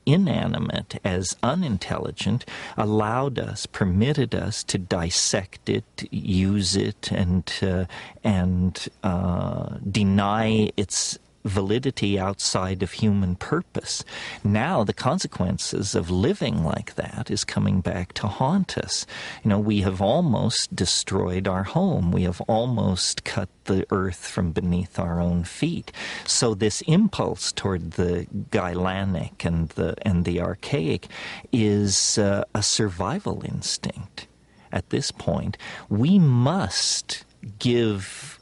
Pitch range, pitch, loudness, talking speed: 90-110 Hz, 100 Hz, -24 LUFS, 120 wpm